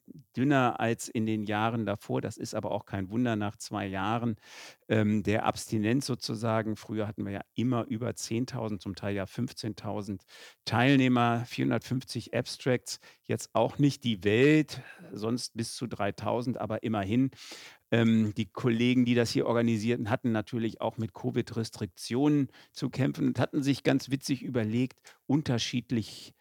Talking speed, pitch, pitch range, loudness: 150 wpm, 115 Hz, 110-125 Hz, -30 LUFS